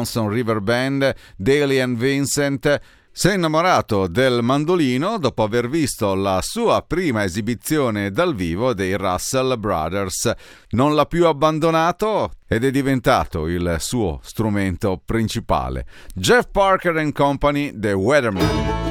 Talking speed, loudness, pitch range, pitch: 125 wpm, -19 LUFS, 100-145 Hz, 120 Hz